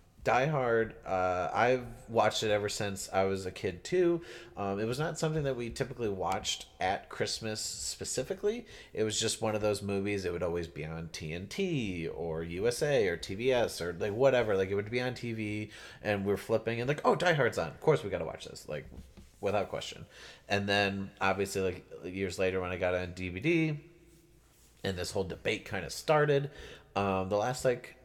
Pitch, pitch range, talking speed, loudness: 110 Hz, 95-130 Hz, 195 wpm, -32 LUFS